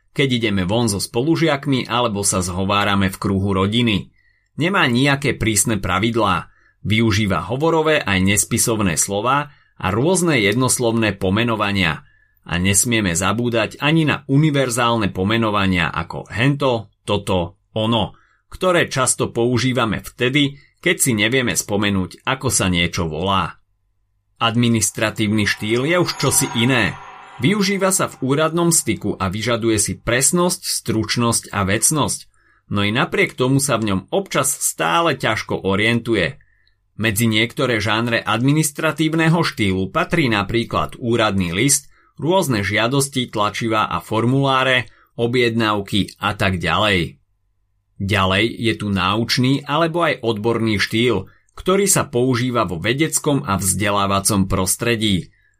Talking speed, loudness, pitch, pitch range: 120 wpm, -18 LUFS, 115 Hz, 100-130 Hz